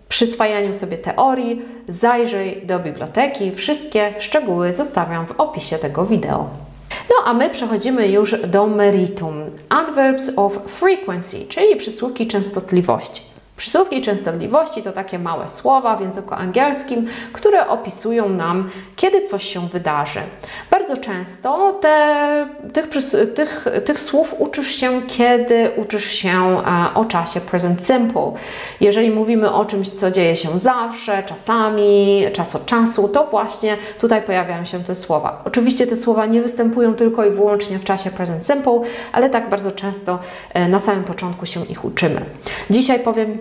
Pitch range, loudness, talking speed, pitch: 190-245 Hz, -18 LUFS, 140 wpm, 210 Hz